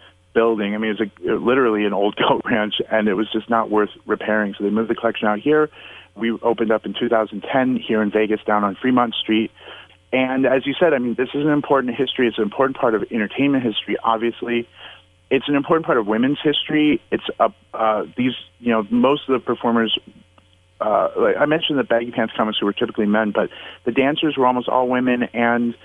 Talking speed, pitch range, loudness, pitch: 220 wpm, 105-130 Hz, -19 LUFS, 115 Hz